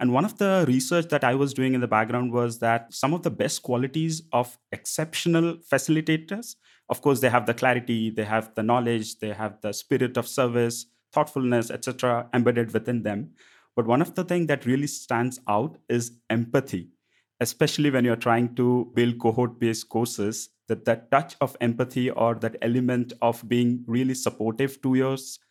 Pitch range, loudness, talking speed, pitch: 115-135 Hz, -25 LUFS, 180 wpm, 125 Hz